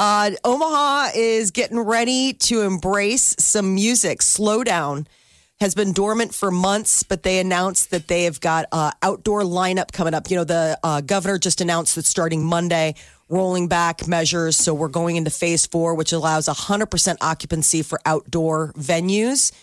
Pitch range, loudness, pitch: 165-205 Hz, -19 LUFS, 180 Hz